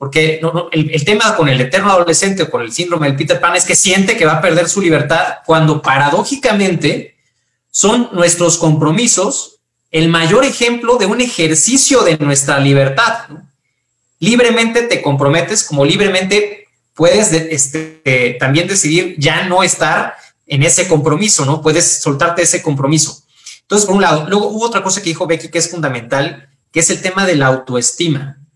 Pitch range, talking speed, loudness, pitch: 150-190 Hz, 175 wpm, -12 LUFS, 165 Hz